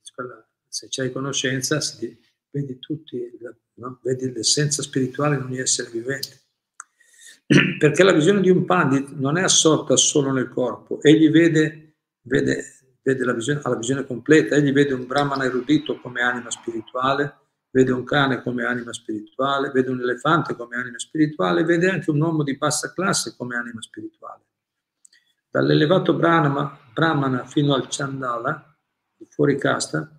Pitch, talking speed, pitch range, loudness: 140 Hz, 145 wpm, 130-155 Hz, -20 LUFS